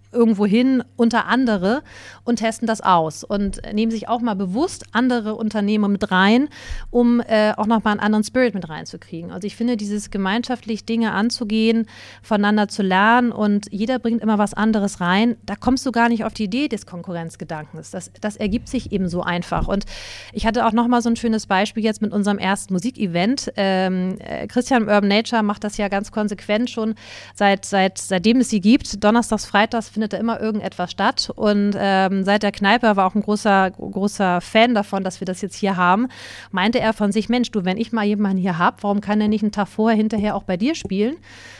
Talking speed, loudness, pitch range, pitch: 205 wpm, -19 LUFS, 200-230 Hz, 210 Hz